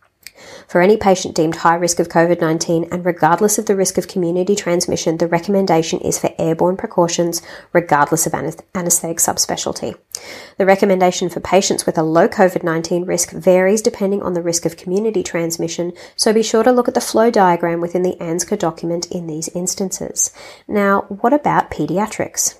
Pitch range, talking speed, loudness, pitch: 170-195 Hz, 175 wpm, -16 LUFS, 180 Hz